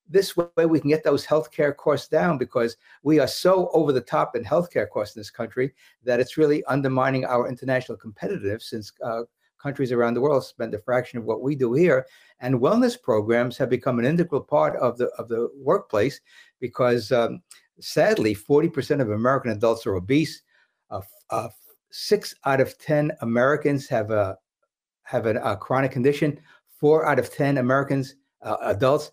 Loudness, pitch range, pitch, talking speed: -23 LUFS, 120-150 Hz, 135 Hz, 175 wpm